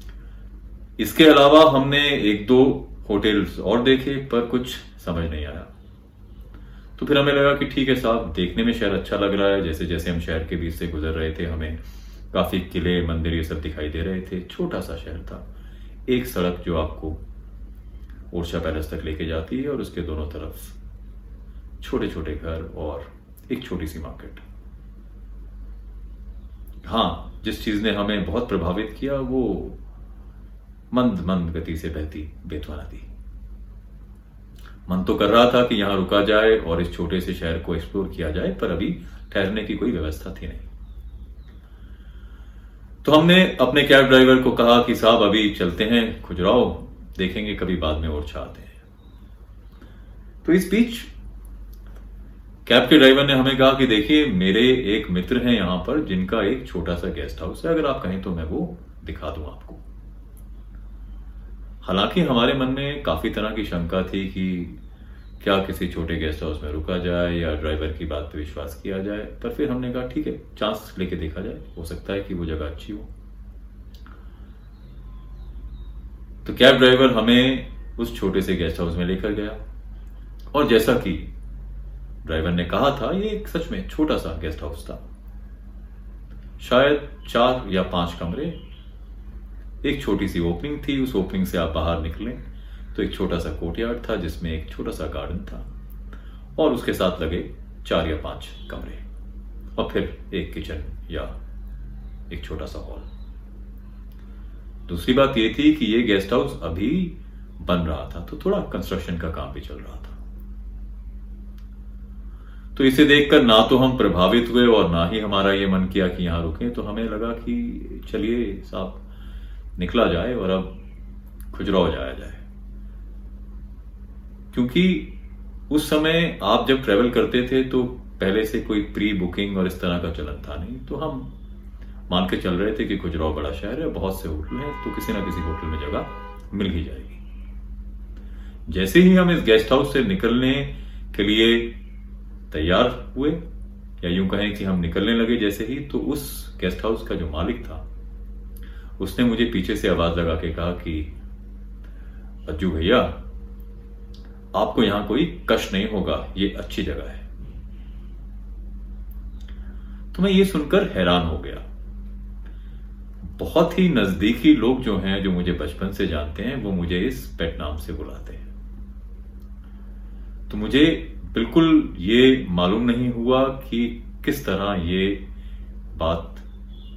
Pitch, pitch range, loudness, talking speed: 90 Hz, 70-110 Hz, -21 LUFS, 160 wpm